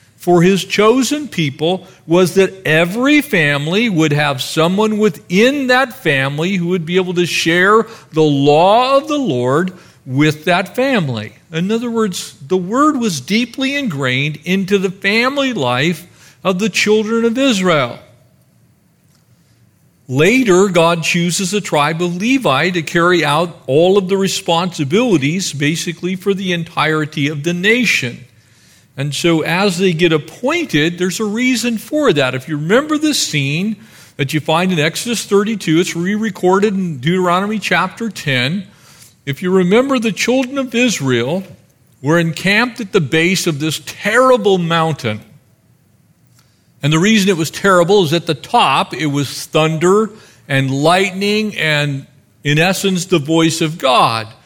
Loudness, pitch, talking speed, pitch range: -14 LUFS, 180 Hz, 145 wpm, 155-210 Hz